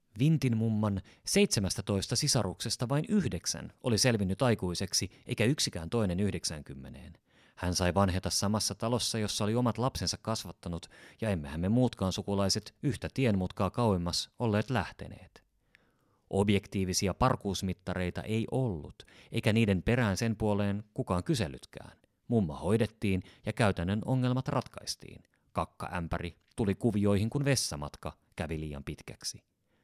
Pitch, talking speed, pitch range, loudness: 105 Hz, 120 wpm, 90-120 Hz, -31 LUFS